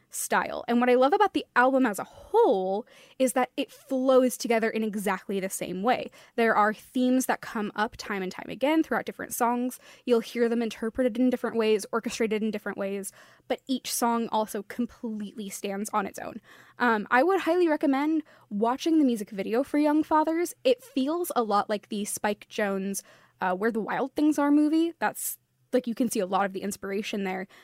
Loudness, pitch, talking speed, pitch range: -27 LUFS, 235 Hz, 200 wpm, 210-265 Hz